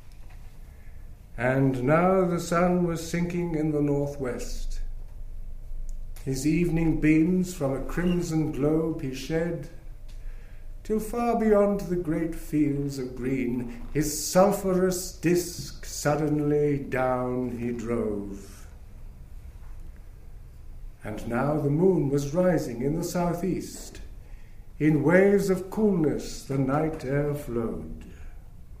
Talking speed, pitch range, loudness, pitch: 105 wpm, 110-165 Hz, -26 LUFS, 145 Hz